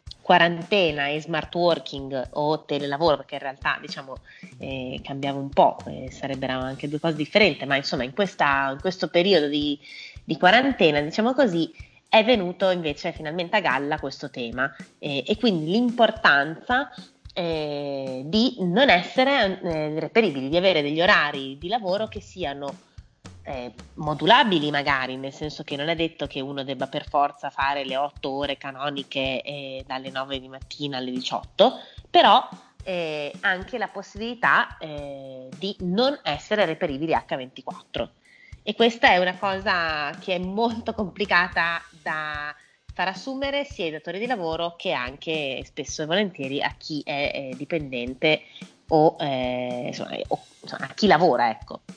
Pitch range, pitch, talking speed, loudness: 140-185 Hz, 155 Hz, 150 wpm, -23 LUFS